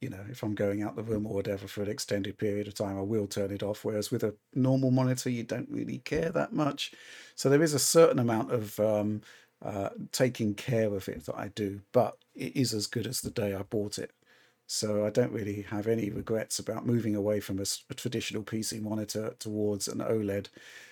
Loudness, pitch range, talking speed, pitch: -31 LUFS, 100-120 Hz, 225 wpm, 105 Hz